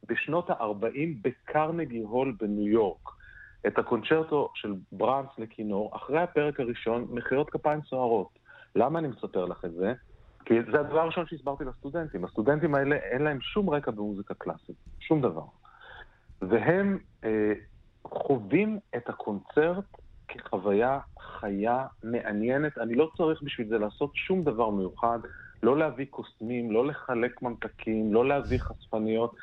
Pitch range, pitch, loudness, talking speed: 110-150 Hz, 125 Hz, -29 LUFS, 135 wpm